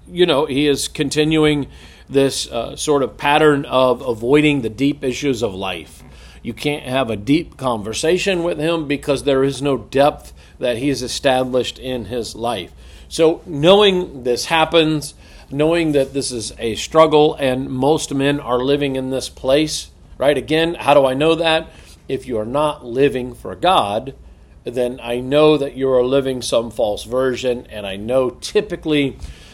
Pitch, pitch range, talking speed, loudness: 135 Hz, 125-150 Hz, 170 wpm, -18 LUFS